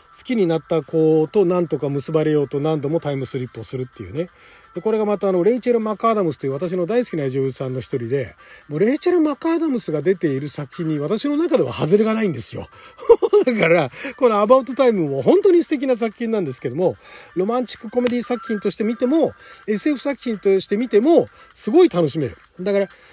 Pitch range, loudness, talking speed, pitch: 150-245 Hz, -19 LUFS, 455 characters per minute, 195 Hz